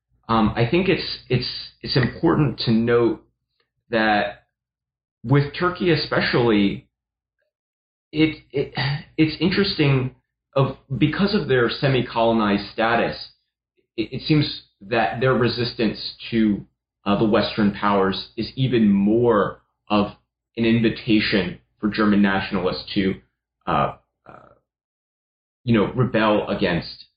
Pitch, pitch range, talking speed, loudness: 115 Hz, 105-140 Hz, 110 wpm, -21 LUFS